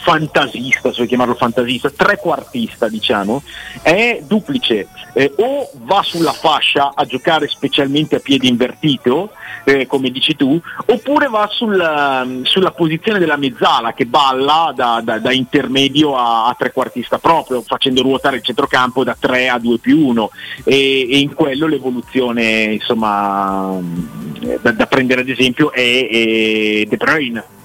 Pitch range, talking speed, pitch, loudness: 125-160 Hz, 140 wpm, 135 Hz, -14 LUFS